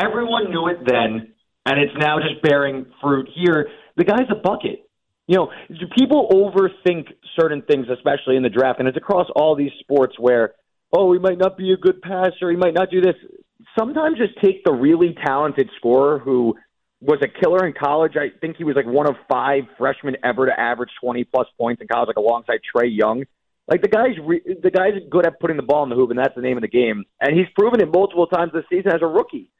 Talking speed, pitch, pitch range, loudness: 225 wpm, 160 Hz, 130-185 Hz, -19 LUFS